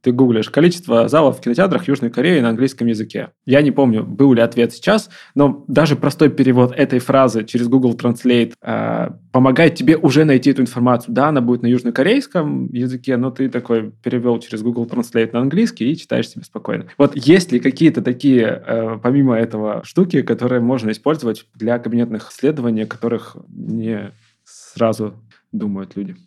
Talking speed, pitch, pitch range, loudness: 170 wpm, 125 Hz, 115-140 Hz, -16 LUFS